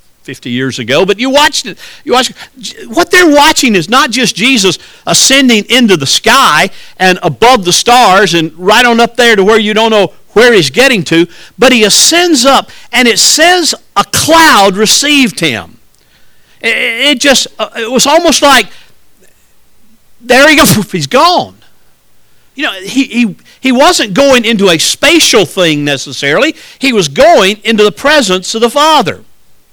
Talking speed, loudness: 165 wpm, -6 LUFS